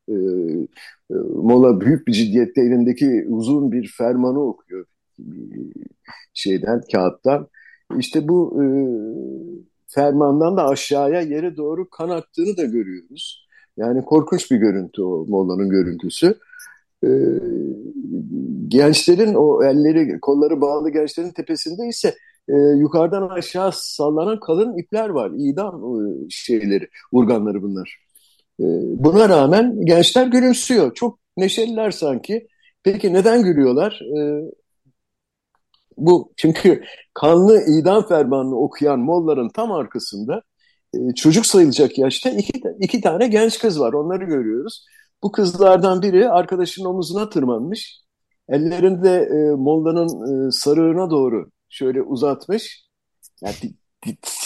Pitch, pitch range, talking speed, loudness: 170 Hz, 140-220 Hz, 110 wpm, -17 LUFS